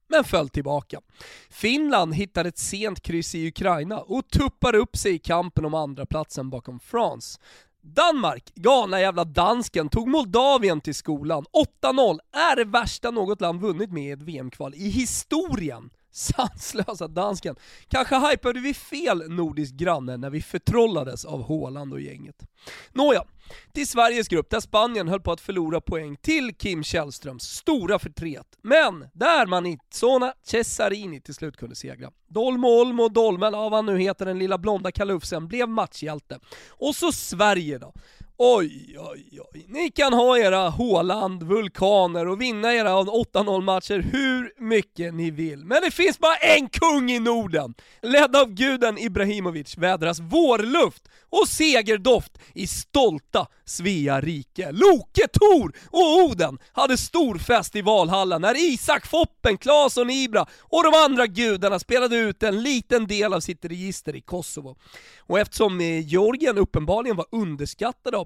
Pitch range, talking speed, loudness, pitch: 165-250 Hz, 150 wpm, -22 LUFS, 205 Hz